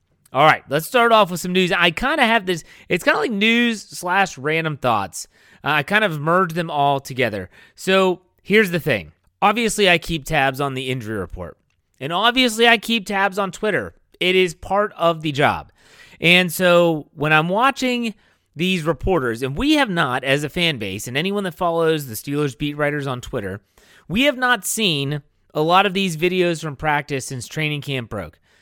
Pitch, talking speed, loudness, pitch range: 170 Hz, 195 wpm, -19 LUFS, 140-200 Hz